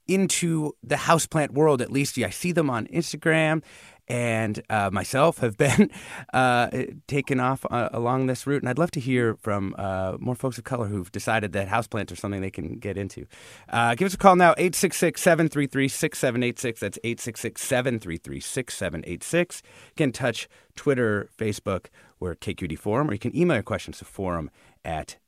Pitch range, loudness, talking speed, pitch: 105-150 Hz, -25 LUFS, 180 wpm, 125 Hz